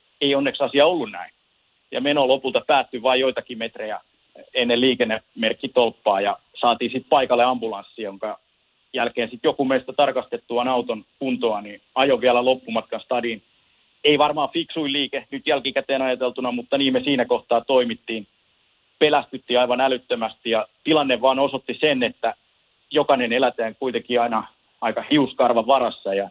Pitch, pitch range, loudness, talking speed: 125 Hz, 120-135 Hz, -21 LUFS, 140 wpm